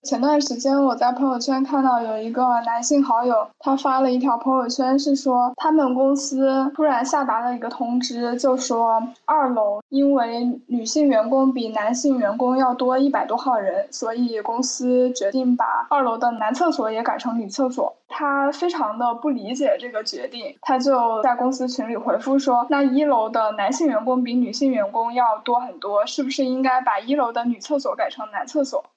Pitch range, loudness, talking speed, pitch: 240-285 Hz, -21 LUFS, 285 characters per minute, 260 Hz